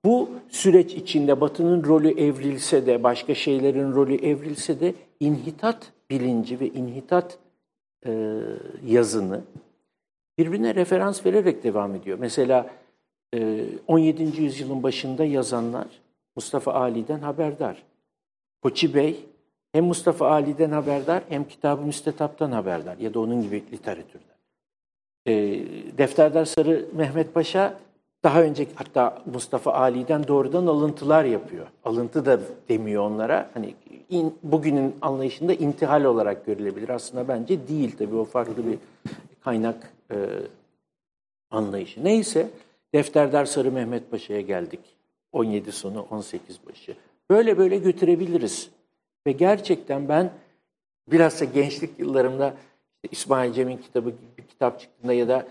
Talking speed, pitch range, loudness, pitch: 120 wpm, 125-165 Hz, -23 LUFS, 145 Hz